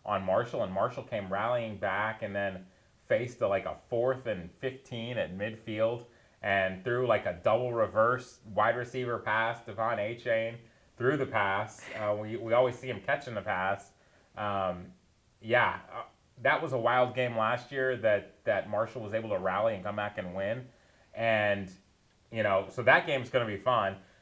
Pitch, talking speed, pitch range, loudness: 110 Hz, 185 wpm, 100-125 Hz, -31 LUFS